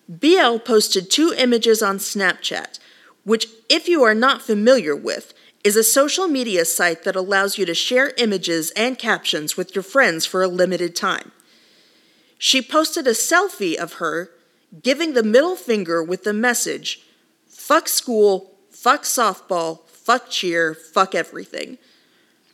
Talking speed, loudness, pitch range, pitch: 145 wpm, -18 LUFS, 185-265 Hz, 225 Hz